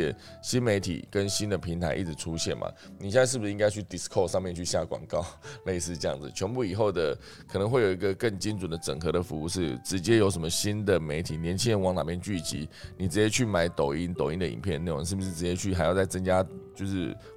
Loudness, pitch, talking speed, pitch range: -29 LUFS, 95 Hz, 365 characters per minute, 85-100 Hz